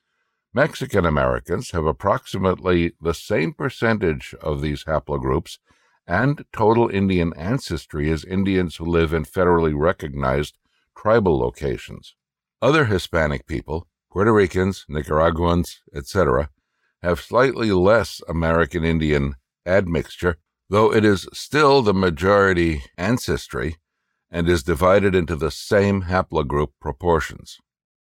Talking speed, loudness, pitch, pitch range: 110 wpm, -20 LUFS, 85 Hz, 75-95 Hz